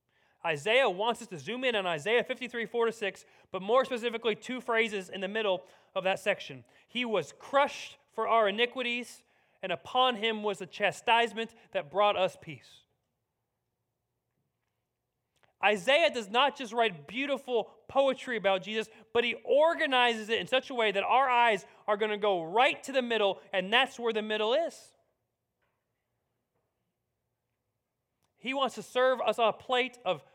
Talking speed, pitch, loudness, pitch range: 160 wpm, 220 Hz, -29 LUFS, 185-245 Hz